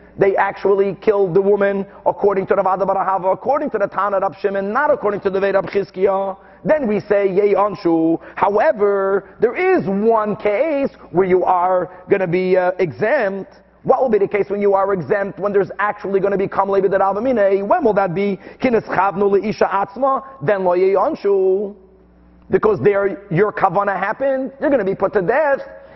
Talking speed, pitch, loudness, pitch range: 185 wpm, 200 Hz, -17 LUFS, 195-210 Hz